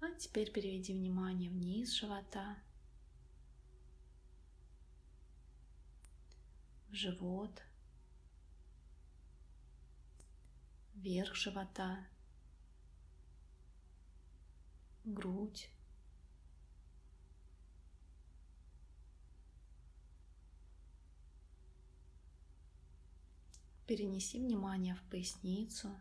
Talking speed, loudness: 35 wpm, -43 LUFS